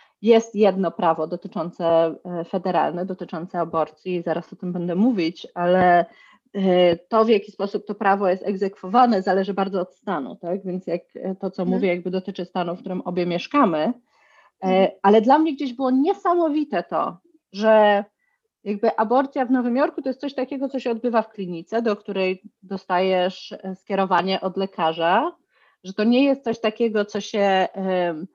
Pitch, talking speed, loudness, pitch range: 195 Hz, 155 wpm, -22 LUFS, 180-230 Hz